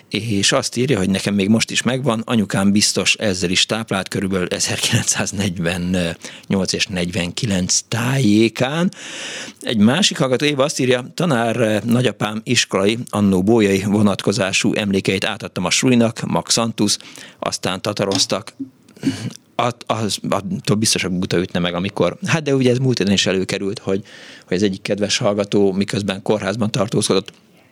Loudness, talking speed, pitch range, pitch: -18 LUFS, 135 wpm, 95-125 Hz, 105 Hz